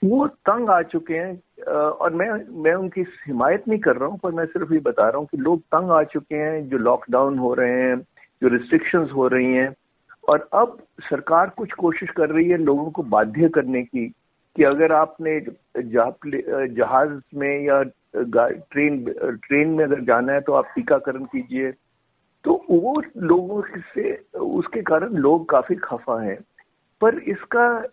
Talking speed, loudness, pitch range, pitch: 170 wpm, -21 LUFS, 135-195 Hz, 160 Hz